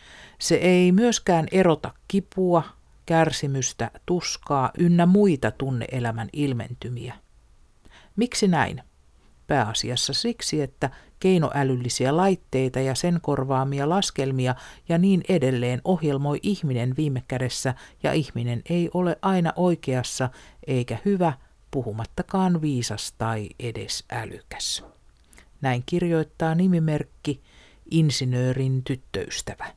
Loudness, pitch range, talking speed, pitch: -24 LUFS, 125-175 Hz, 95 wpm, 140 Hz